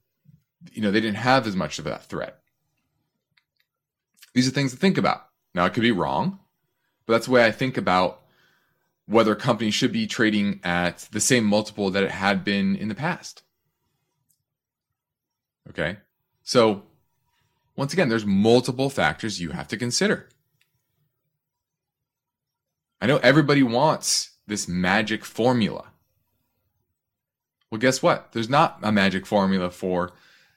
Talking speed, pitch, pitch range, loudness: 140 wpm, 115 Hz, 100-135 Hz, -22 LUFS